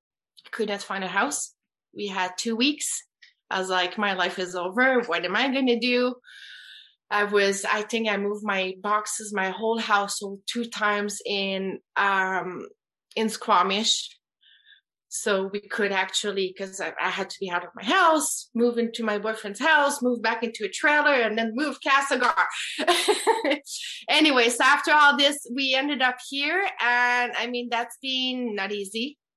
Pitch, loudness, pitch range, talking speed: 230 Hz, -24 LUFS, 200-265 Hz, 170 wpm